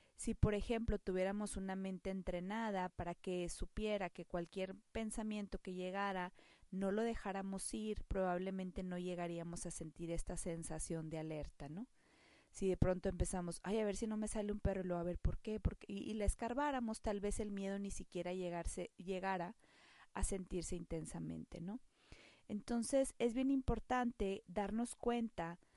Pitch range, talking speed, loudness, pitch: 180-215 Hz, 170 wpm, -43 LUFS, 195 Hz